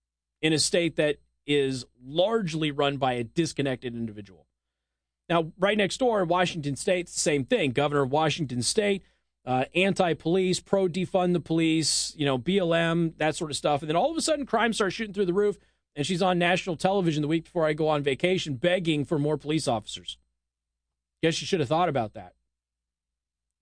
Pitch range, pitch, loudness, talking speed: 130-180 Hz, 155 Hz, -26 LUFS, 190 wpm